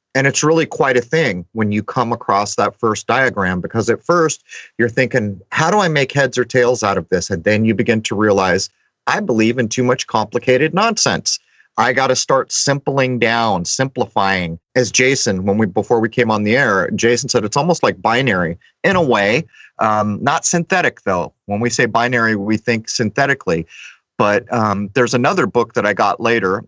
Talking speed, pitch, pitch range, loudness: 195 wpm, 120 Hz, 110-135 Hz, -16 LUFS